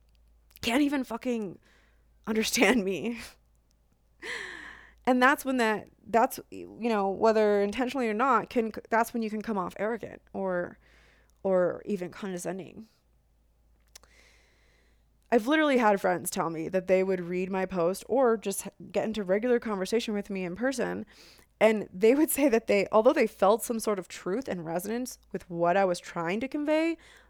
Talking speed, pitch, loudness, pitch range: 160 wpm, 205 Hz, -28 LUFS, 180-230 Hz